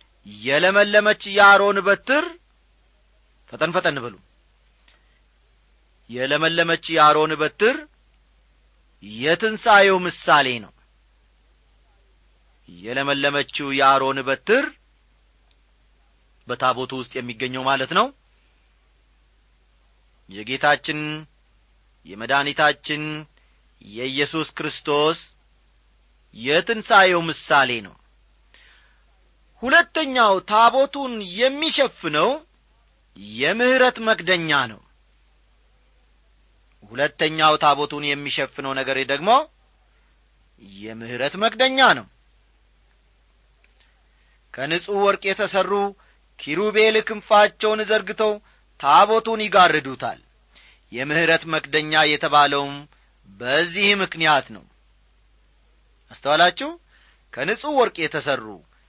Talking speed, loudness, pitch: 60 wpm, -19 LUFS, 150 Hz